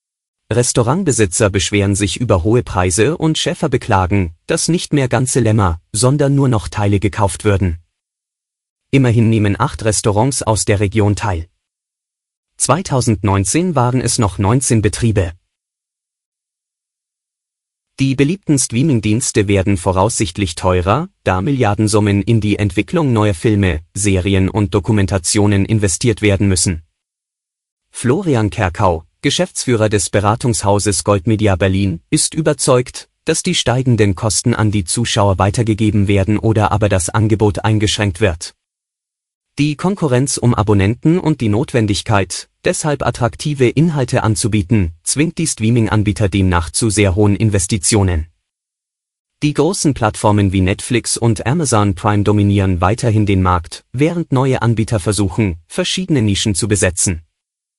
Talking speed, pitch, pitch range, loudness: 120 wpm, 105 Hz, 100-125 Hz, -15 LUFS